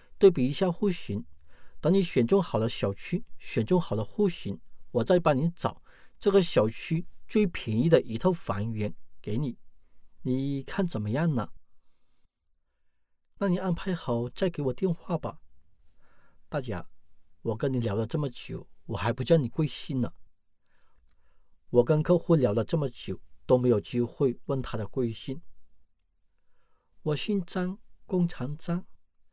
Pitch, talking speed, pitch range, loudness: 125 Hz, 205 characters per minute, 100-170 Hz, -29 LUFS